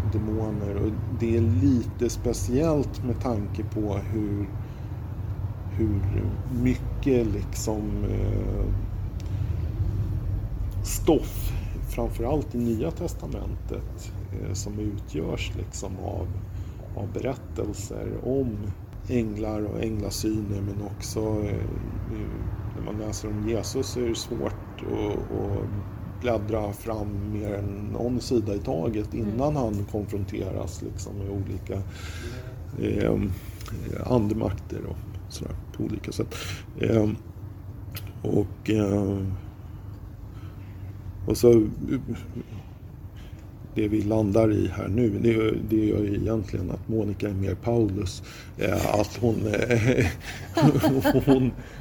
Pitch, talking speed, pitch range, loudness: 105 Hz, 100 wpm, 100-110 Hz, -27 LUFS